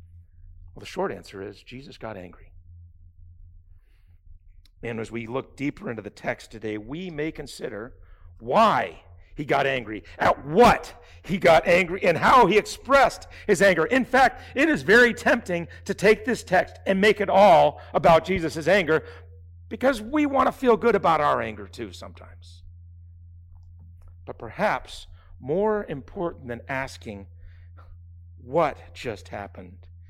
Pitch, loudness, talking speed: 105 Hz, -22 LUFS, 145 wpm